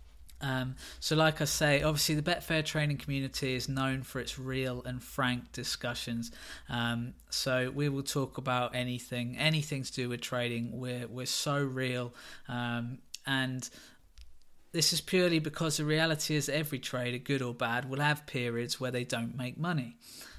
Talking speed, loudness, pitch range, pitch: 165 wpm, -32 LUFS, 125-150 Hz, 130 Hz